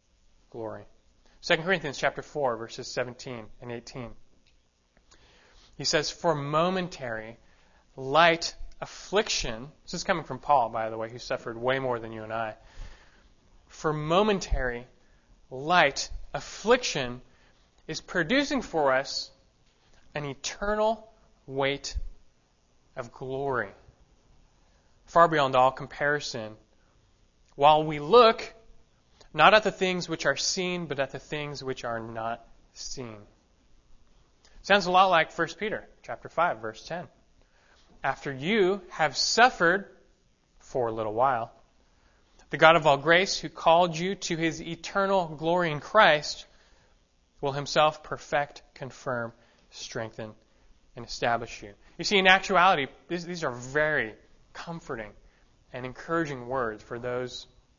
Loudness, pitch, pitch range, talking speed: -26 LUFS, 140 Hz, 120-170 Hz, 125 wpm